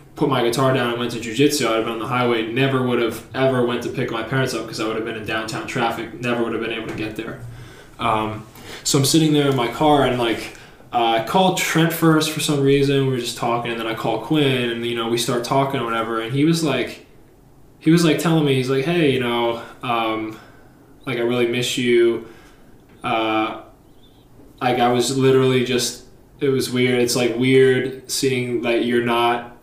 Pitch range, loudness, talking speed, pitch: 115-135 Hz, -19 LUFS, 225 wpm, 120 Hz